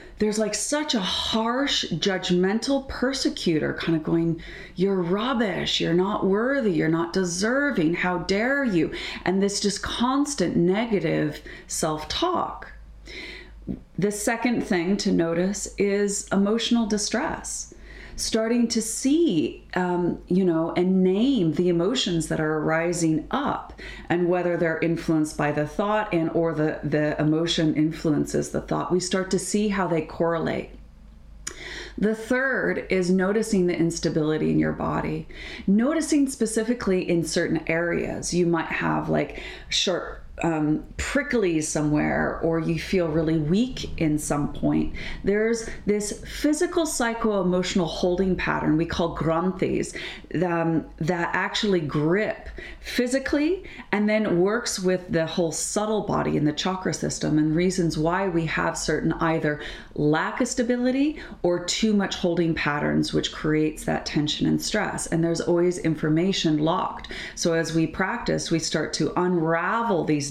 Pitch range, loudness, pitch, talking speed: 160-215 Hz, -24 LUFS, 180 Hz, 140 wpm